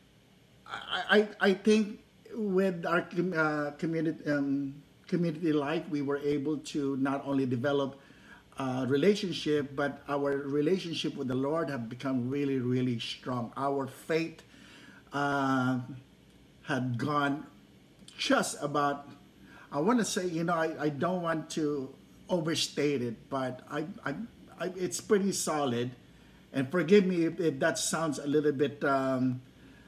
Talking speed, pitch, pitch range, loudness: 135 wpm, 145 Hz, 135-165 Hz, -31 LUFS